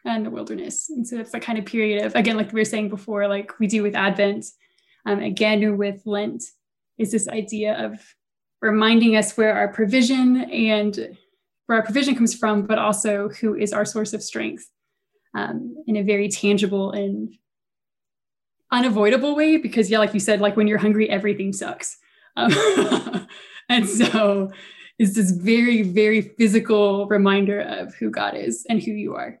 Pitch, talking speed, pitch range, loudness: 215 Hz, 175 wpm, 205-230 Hz, -21 LUFS